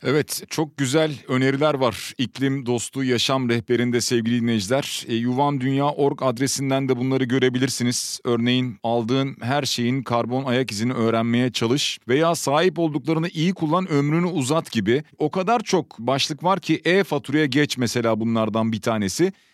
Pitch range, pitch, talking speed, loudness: 120-150 Hz, 135 Hz, 145 wpm, -22 LUFS